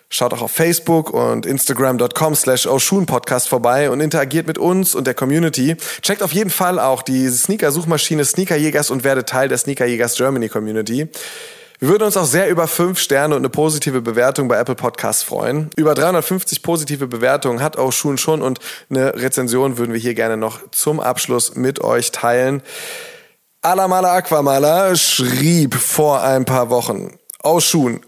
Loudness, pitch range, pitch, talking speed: -16 LUFS, 130-165 Hz, 145 Hz, 165 wpm